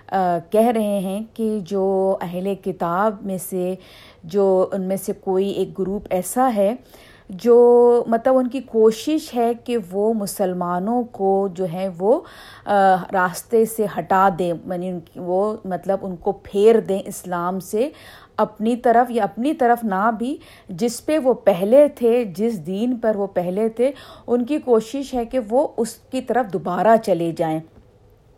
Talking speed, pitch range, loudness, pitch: 165 wpm, 190-235 Hz, -20 LUFS, 200 Hz